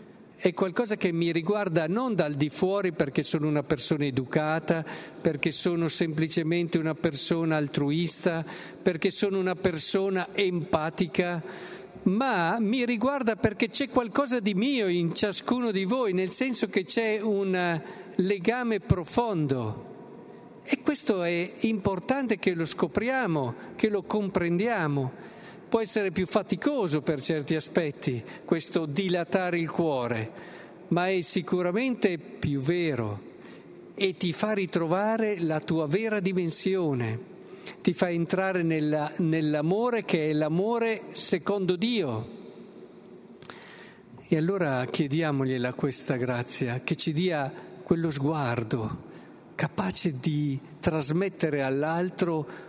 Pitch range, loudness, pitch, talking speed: 160-205 Hz, -27 LUFS, 180 Hz, 115 wpm